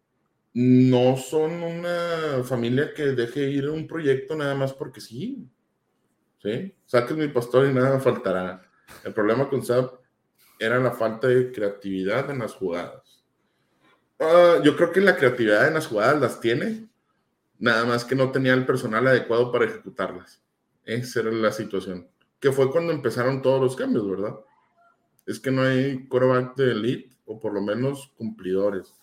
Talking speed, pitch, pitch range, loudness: 160 wpm, 130 Hz, 115-140 Hz, -23 LUFS